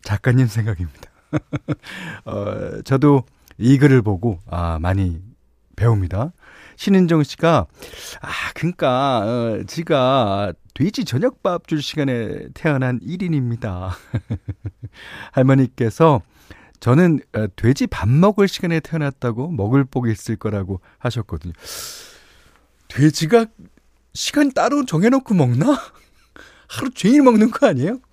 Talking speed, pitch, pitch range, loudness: 235 characters per minute, 130 Hz, 105-165 Hz, -19 LUFS